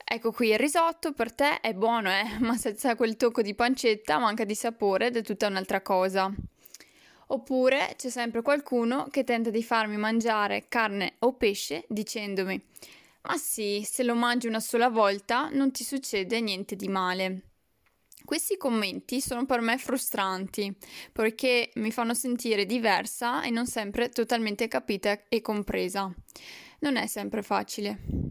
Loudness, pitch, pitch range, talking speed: -28 LUFS, 230 Hz, 210-245 Hz, 155 wpm